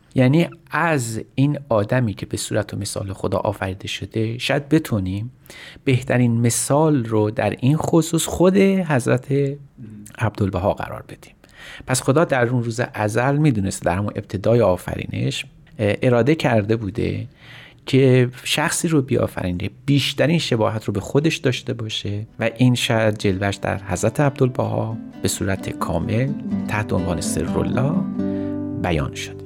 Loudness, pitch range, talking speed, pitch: -20 LUFS, 105-140 Hz, 135 wpm, 120 Hz